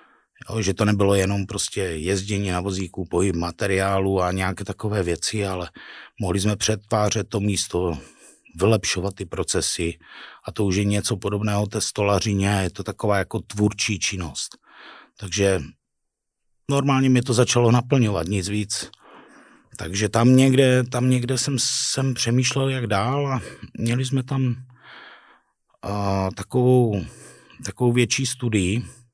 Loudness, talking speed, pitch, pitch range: -22 LUFS, 130 wpm, 105 Hz, 95-120 Hz